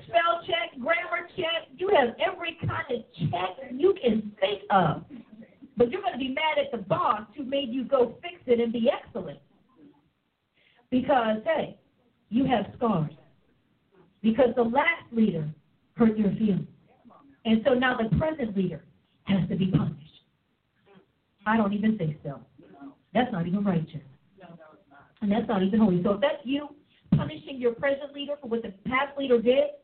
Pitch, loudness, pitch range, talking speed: 235 Hz, -27 LUFS, 190-275 Hz, 160 wpm